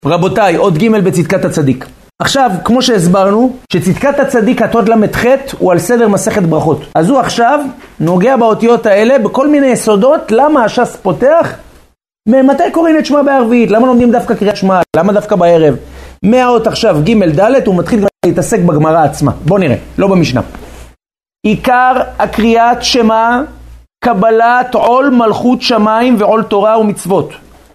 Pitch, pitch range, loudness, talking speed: 225 Hz, 190-245 Hz, -9 LUFS, 145 wpm